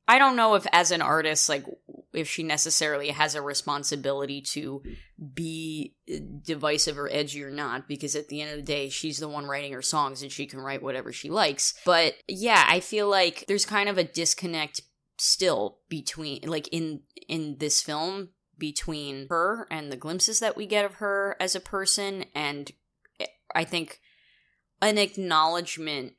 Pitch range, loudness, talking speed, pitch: 145-180 Hz, -26 LUFS, 175 wpm, 155 Hz